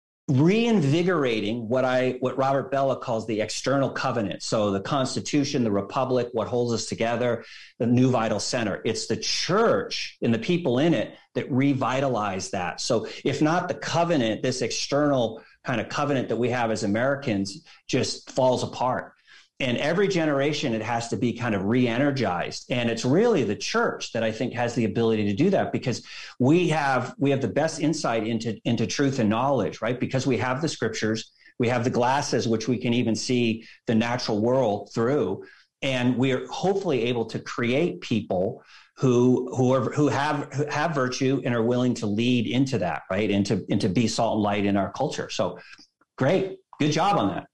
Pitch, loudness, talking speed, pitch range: 125 Hz, -25 LUFS, 185 wpm, 115-135 Hz